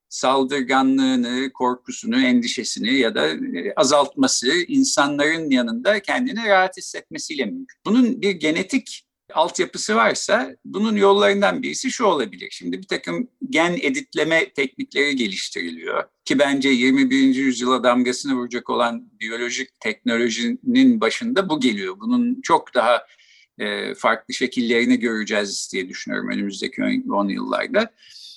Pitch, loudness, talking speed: 195 Hz, -20 LUFS, 110 wpm